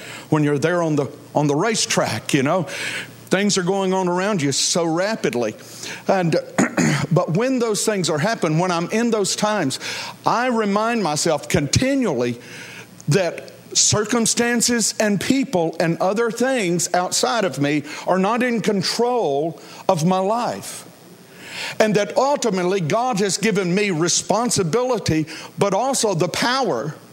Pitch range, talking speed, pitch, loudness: 165-225 Hz, 140 wpm, 190 Hz, -20 LUFS